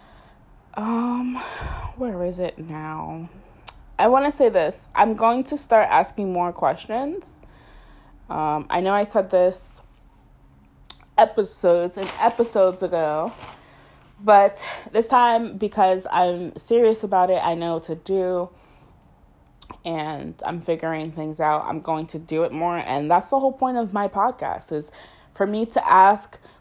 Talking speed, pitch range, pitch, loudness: 145 wpm, 165-225 Hz, 185 Hz, -21 LUFS